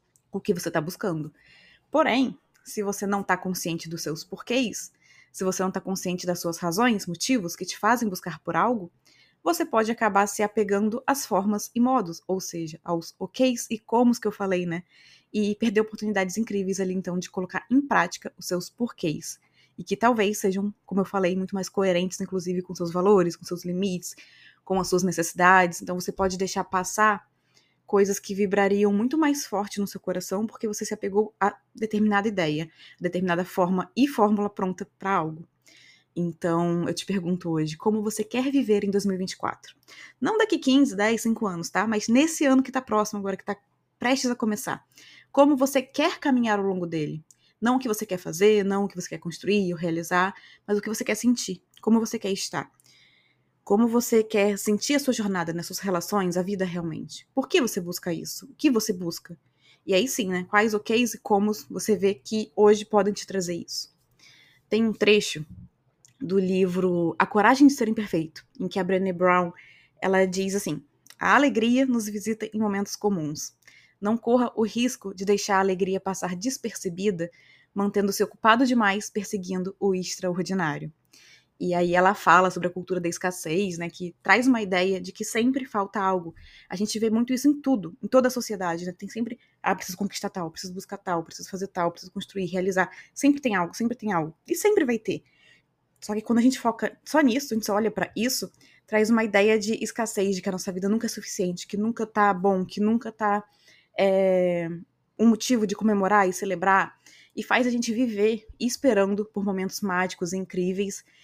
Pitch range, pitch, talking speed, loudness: 180-220 Hz, 200 Hz, 195 wpm, -25 LUFS